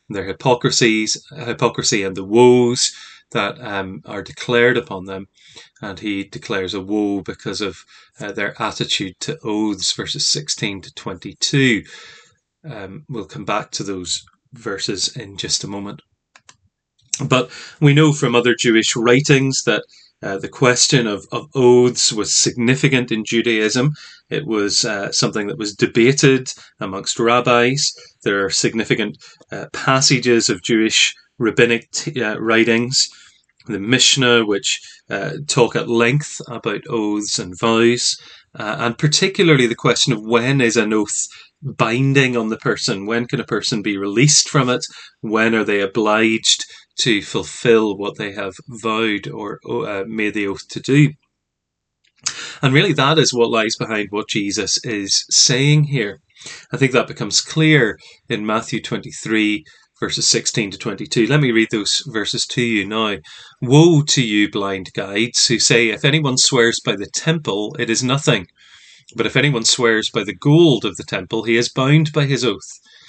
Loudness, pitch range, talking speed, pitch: -17 LUFS, 110-135 Hz, 155 wpm, 120 Hz